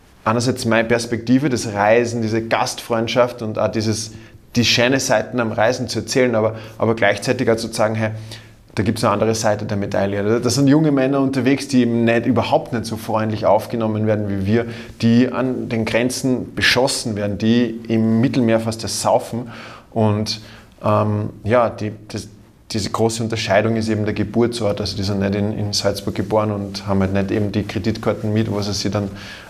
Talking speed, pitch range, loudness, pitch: 185 wpm, 105-120 Hz, -19 LUFS, 110 Hz